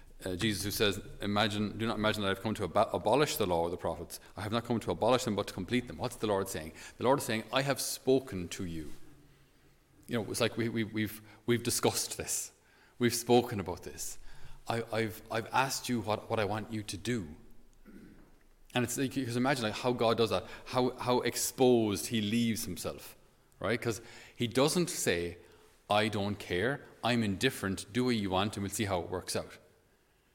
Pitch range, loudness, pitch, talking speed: 100-120 Hz, -32 LUFS, 110 Hz, 220 wpm